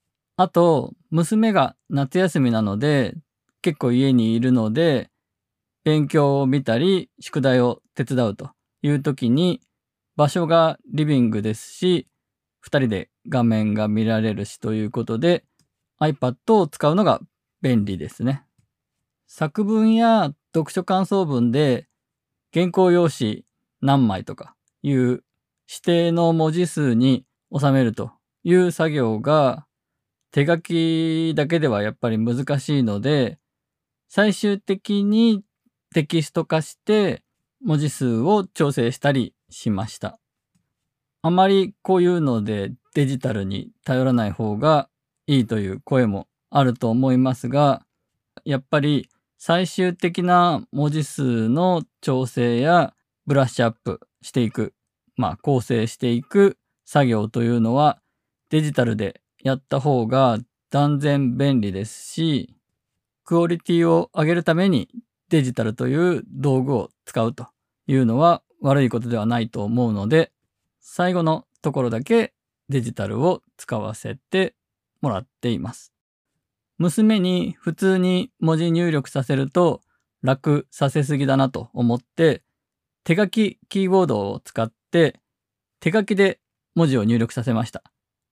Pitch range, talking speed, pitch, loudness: 120-170 Hz, 245 characters per minute, 140 Hz, -21 LUFS